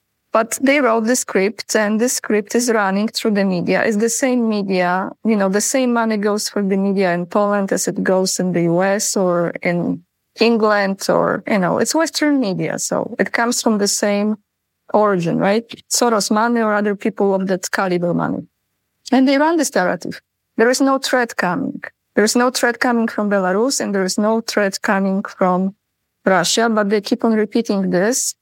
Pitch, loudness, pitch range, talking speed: 215 Hz, -17 LUFS, 195-235 Hz, 190 wpm